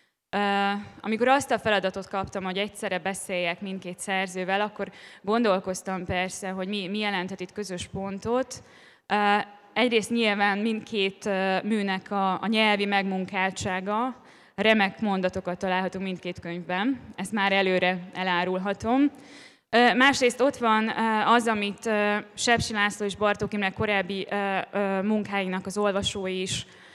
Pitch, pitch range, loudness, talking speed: 200 Hz, 190-215 Hz, -26 LUFS, 110 wpm